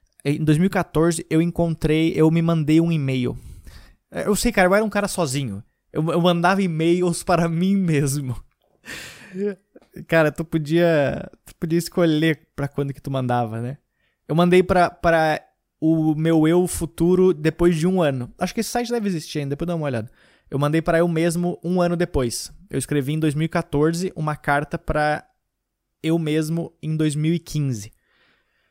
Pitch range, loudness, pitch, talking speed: 150-175 Hz, -21 LUFS, 165 Hz, 160 wpm